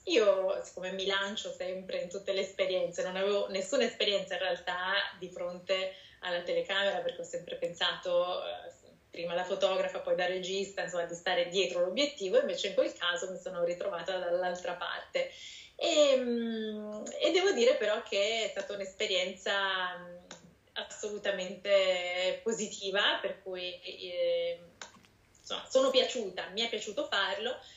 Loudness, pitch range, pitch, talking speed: -32 LUFS, 185-235 Hz, 195 Hz, 140 wpm